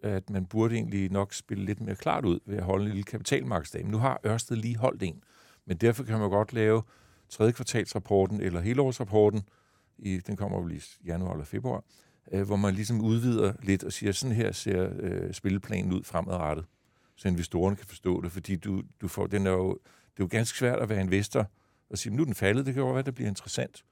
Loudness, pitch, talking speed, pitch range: -30 LUFS, 105 Hz, 230 wpm, 95-115 Hz